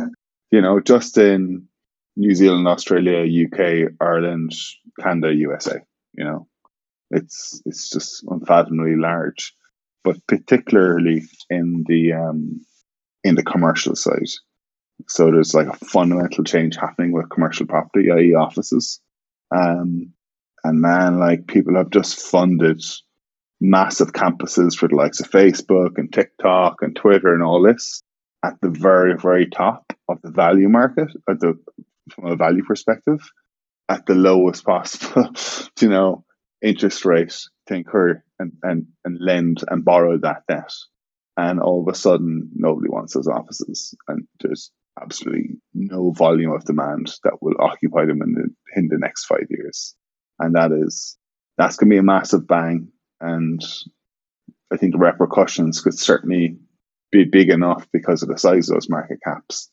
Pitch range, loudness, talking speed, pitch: 85-95 Hz, -18 LUFS, 150 wpm, 85 Hz